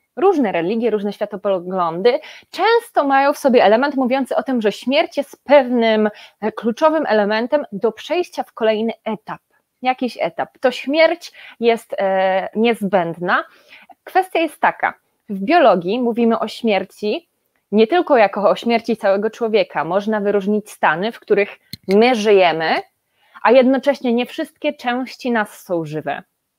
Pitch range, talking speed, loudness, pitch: 205-270 Hz, 135 wpm, -17 LUFS, 230 Hz